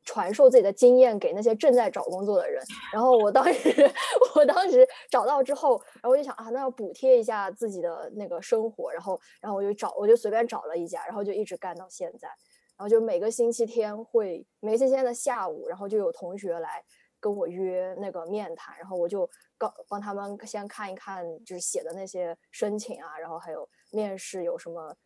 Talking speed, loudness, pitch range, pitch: 315 characters per minute, -25 LUFS, 195-265 Hz, 225 Hz